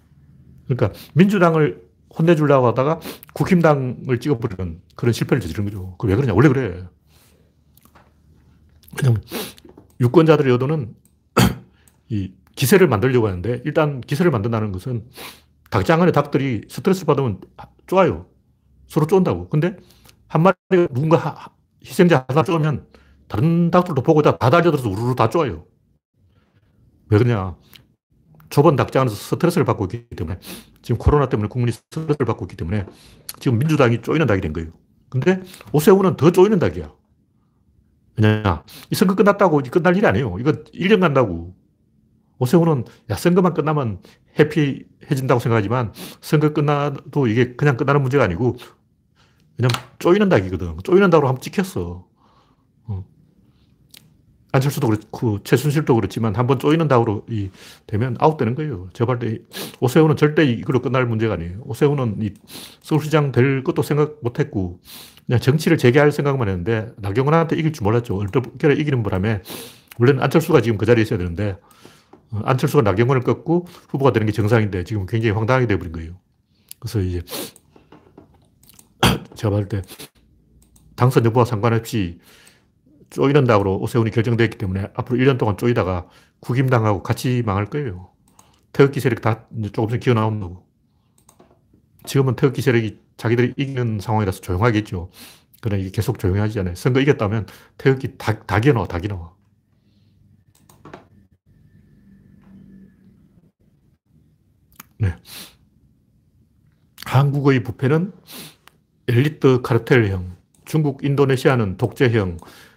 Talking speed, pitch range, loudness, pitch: 325 characters per minute, 105-150 Hz, -19 LUFS, 125 Hz